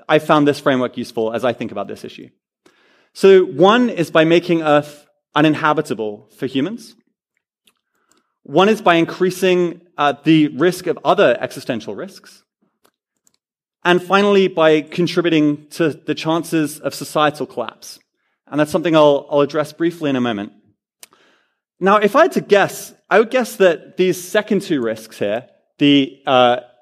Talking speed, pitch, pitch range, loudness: 150 wpm, 155 Hz, 145-180 Hz, -16 LUFS